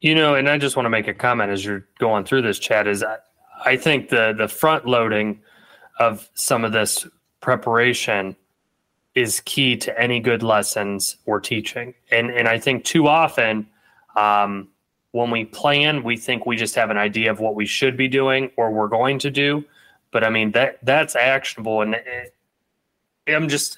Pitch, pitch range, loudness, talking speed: 115 Hz, 105-135 Hz, -19 LUFS, 190 wpm